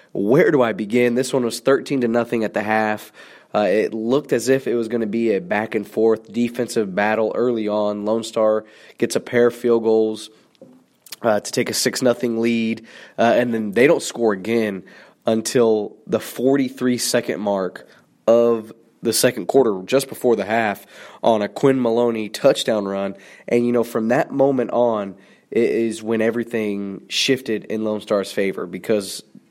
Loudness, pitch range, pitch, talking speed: -20 LUFS, 110-120 Hz, 115 Hz, 185 wpm